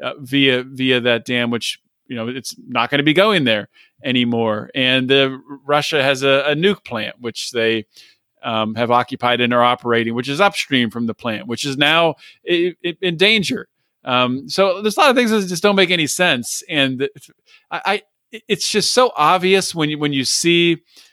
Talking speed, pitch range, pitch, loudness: 195 wpm, 120-180 Hz, 140 Hz, -17 LUFS